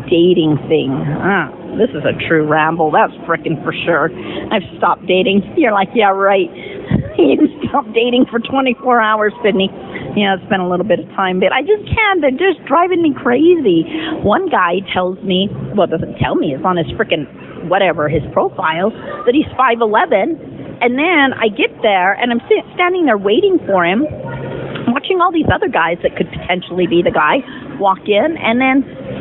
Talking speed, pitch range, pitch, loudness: 185 wpm, 185-295 Hz, 225 Hz, -14 LUFS